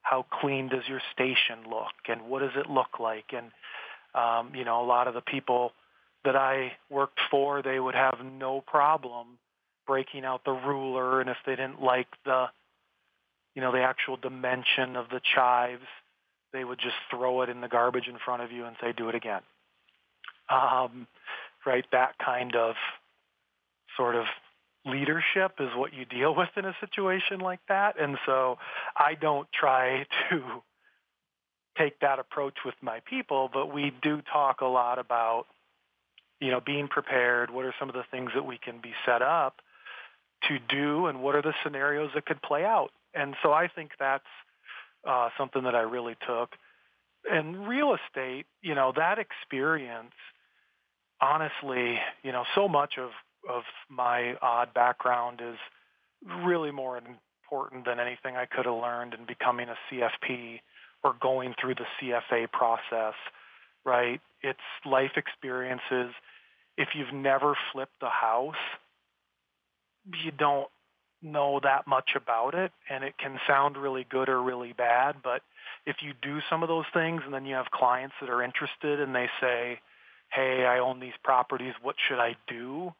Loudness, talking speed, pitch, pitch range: -29 LUFS, 165 wpm, 130 Hz, 125-140 Hz